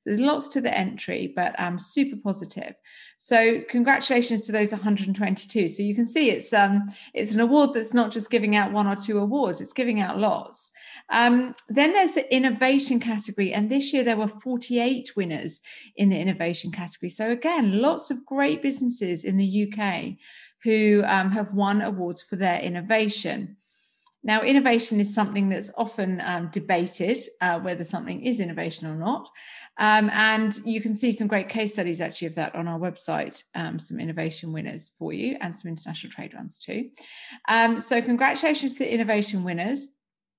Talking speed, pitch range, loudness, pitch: 180 wpm, 195-245 Hz, -24 LUFS, 215 Hz